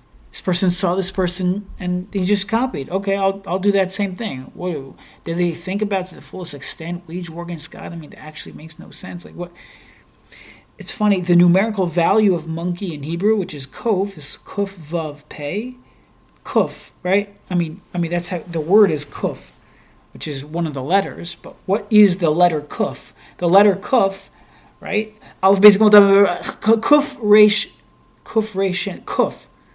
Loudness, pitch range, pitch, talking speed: -19 LUFS, 170-205 Hz, 185 Hz, 180 wpm